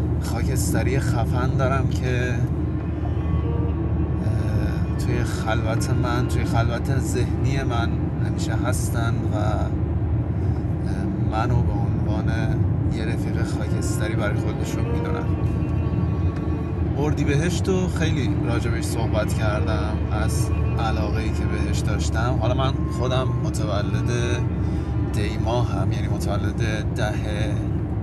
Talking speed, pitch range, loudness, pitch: 95 wpm, 95-110 Hz, -23 LUFS, 105 Hz